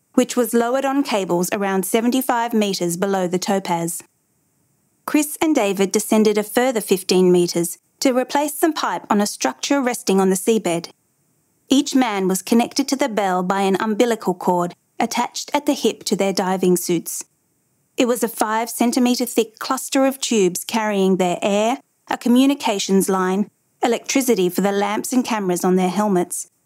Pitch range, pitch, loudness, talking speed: 190-255 Hz, 215 Hz, -19 LUFS, 165 wpm